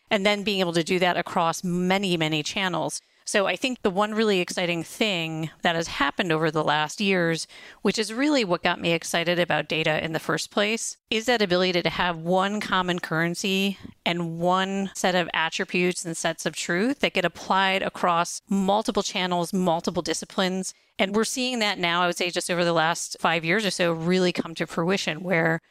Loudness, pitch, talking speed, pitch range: -24 LUFS, 180 Hz, 200 wpm, 170-200 Hz